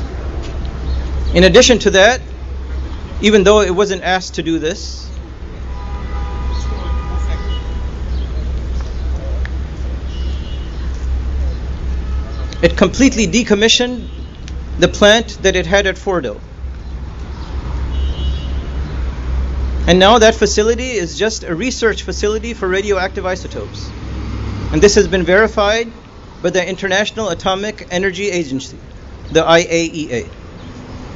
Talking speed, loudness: 90 wpm, -15 LUFS